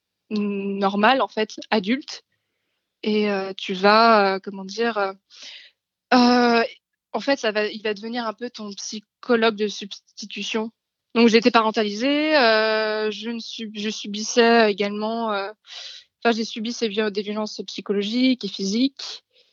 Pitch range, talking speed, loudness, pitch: 210-235 Hz, 145 wpm, -21 LUFS, 220 Hz